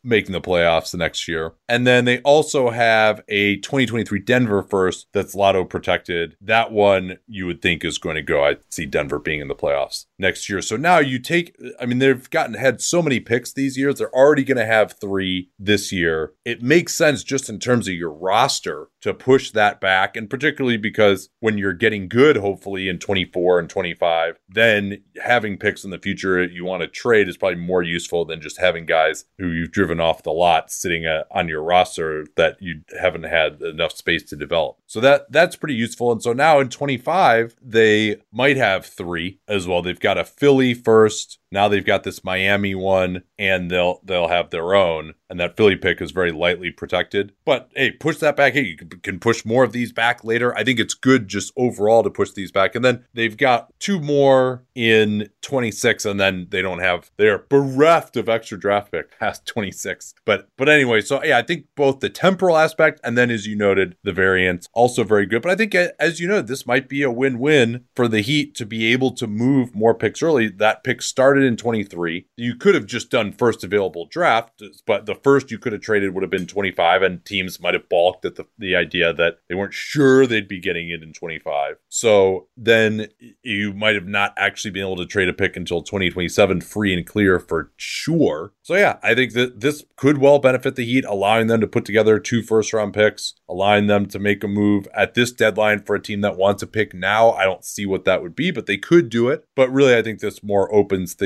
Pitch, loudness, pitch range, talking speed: 110 Hz, -19 LUFS, 95-125 Hz, 220 wpm